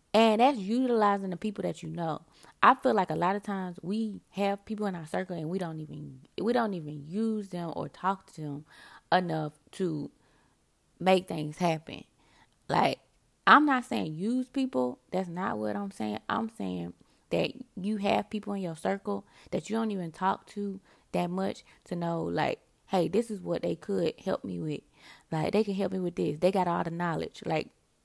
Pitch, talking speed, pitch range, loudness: 185 Hz, 195 wpm, 160-210 Hz, -30 LUFS